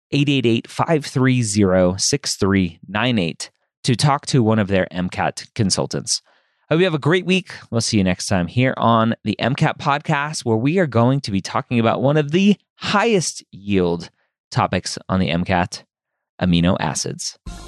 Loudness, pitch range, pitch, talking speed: -19 LUFS, 95-145 Hz, 115 Hz, 155 wpm